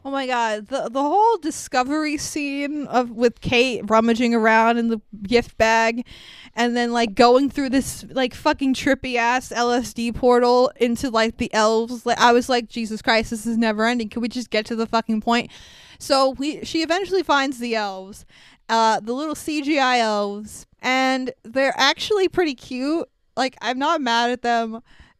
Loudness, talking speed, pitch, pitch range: -20 LUFS, 175 wpm, 240 Hz, 230-270 Hz